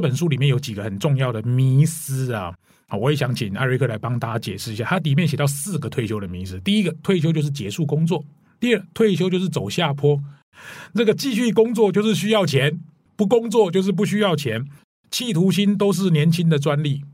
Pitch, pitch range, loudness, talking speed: 155 Hz, 130-195 Hz, -20 LUFS, 325 characters per minute